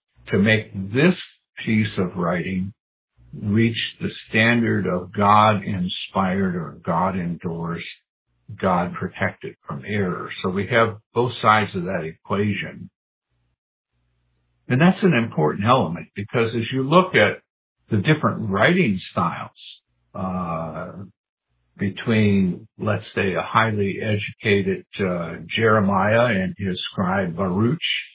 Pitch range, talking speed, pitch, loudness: 90-115 Hz, 115 wpm, 100 Hz, -21 LUFS